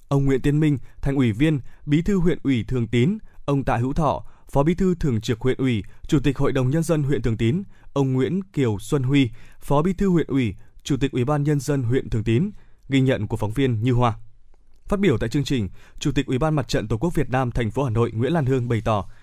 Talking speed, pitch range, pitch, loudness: 260 wpm, 120-150 Hz, 135 Hz, -23 LUFS